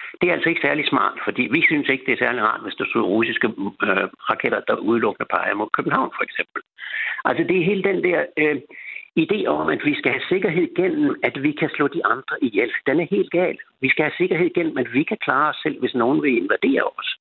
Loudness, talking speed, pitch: -20 LUFS, 240 wpm, 295 Hz